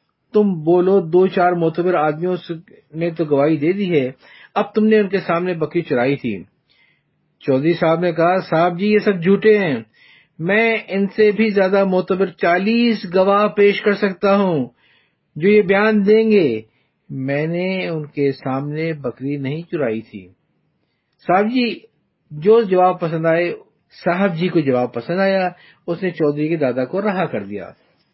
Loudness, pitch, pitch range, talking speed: -17 LUFS, 175 Hz, 150-195 Hz, 165 wpm